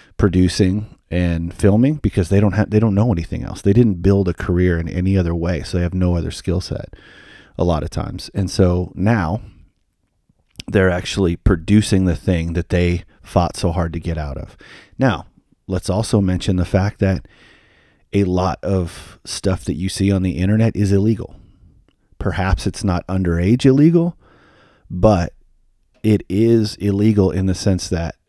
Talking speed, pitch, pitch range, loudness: 170 wpm, 95 Hz, 90-105 Hz, -18 LUFS